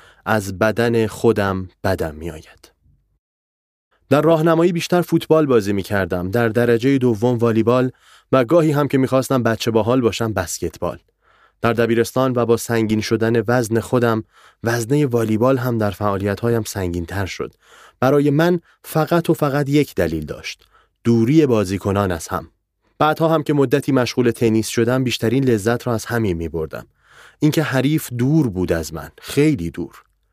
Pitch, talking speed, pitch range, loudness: 115 Hz, 155 wpm, 105-135 Hz, -18 LUFS